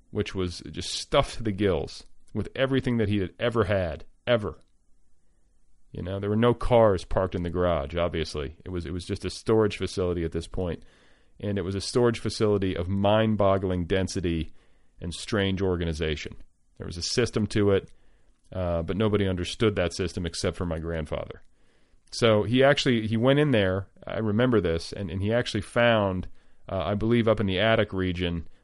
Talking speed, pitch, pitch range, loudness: 190 wpm, 95 Hz, 85-110 Hz, -26 LUFS